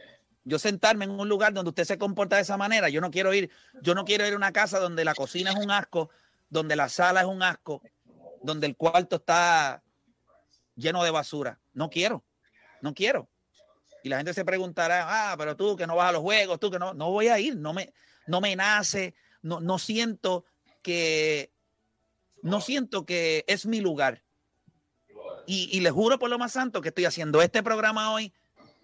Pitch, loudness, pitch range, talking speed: 180 Hz, -26 LUFS, 160-205 Hz, 200 wpm